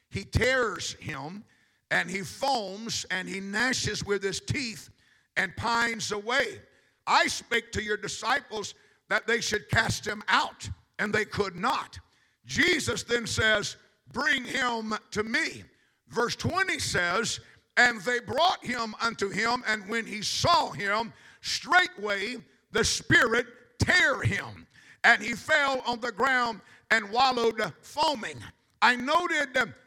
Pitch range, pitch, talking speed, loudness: 205-245 Hz, 230 Hz, 135 wpm, -27 LUFS